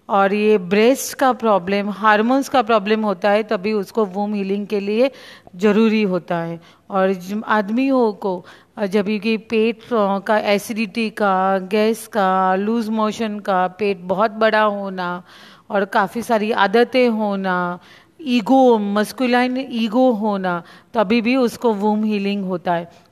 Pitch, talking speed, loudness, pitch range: 215 Hz, 140 wpm, -18 LUFS, 195-230 Hz